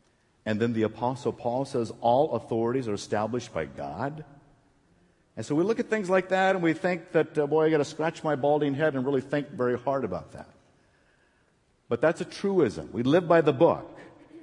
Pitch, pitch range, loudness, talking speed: 145 Hz, 120-160 Hz, -27 LUFS, 205 wpm